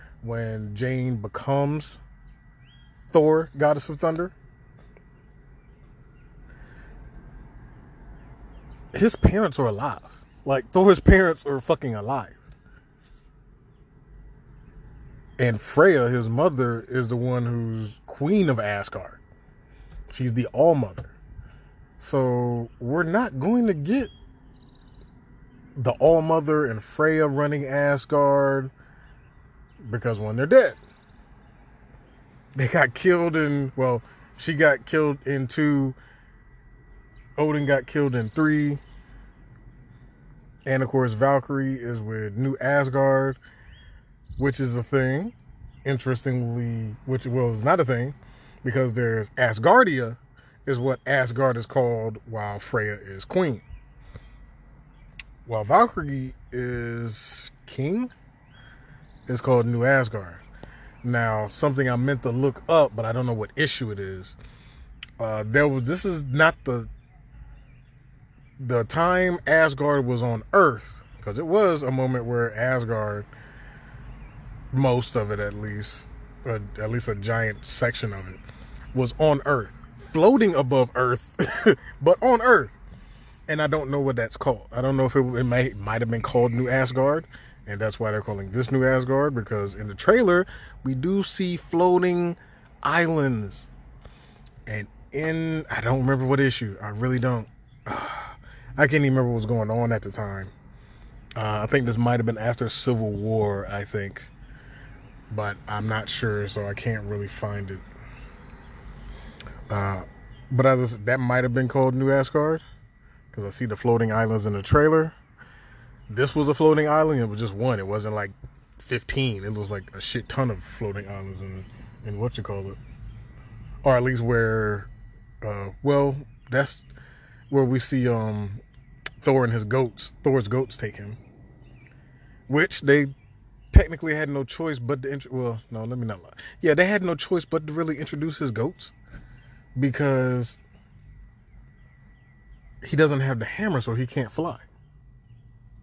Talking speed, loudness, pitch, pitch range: 140 wpm, -24 LUFS, 130 Hz, 115-140 Hz